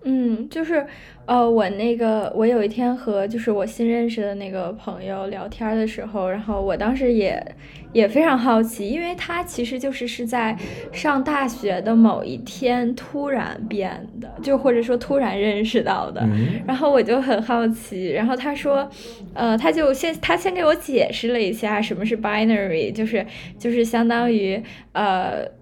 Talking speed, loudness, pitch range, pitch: 260 characters per minute, -21 LUFS, 205-250 Hz, 230 Hz